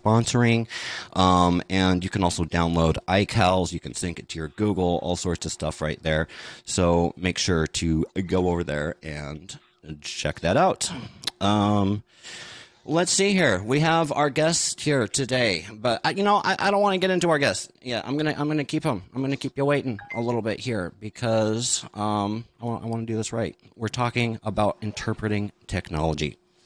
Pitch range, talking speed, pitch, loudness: 90-130 Hz, 190 wpm, 105 Hz, -24 LUFS